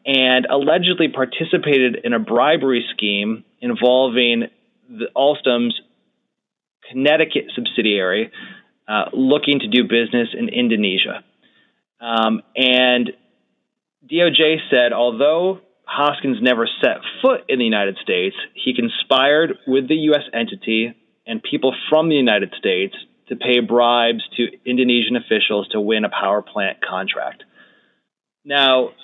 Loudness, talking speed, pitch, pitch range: -17 LUFS, 120 wpm, 130 Hz, 120-160 Hz